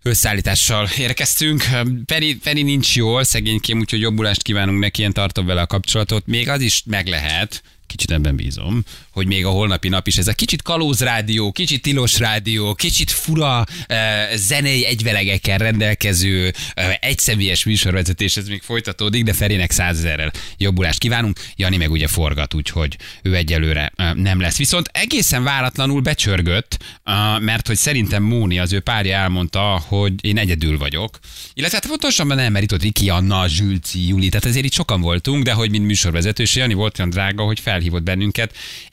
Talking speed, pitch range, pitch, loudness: 160 wpm, 95-115 Hz, 105 Hz, -17 LUFS